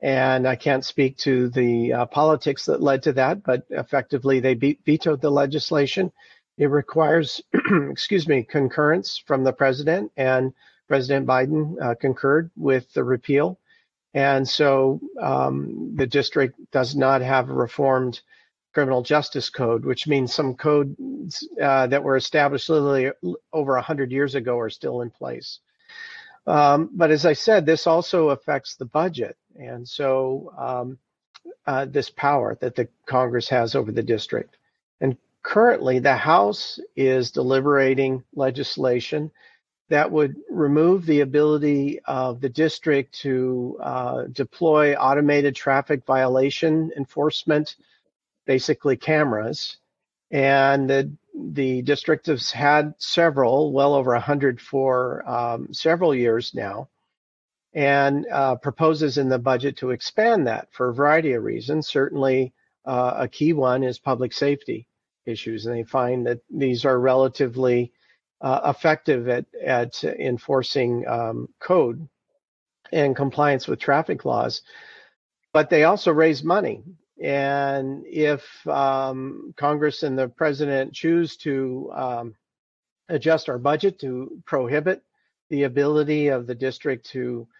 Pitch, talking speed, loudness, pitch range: 140 Hz, 135 wpm, -22 LUFS, 130-150 Hz